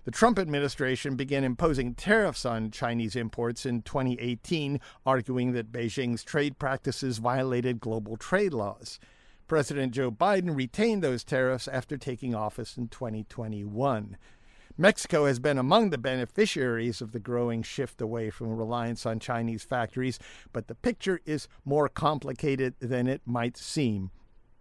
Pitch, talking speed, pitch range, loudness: 130 Hz, 140 wpm, 120-140 Hz, -29 LUFS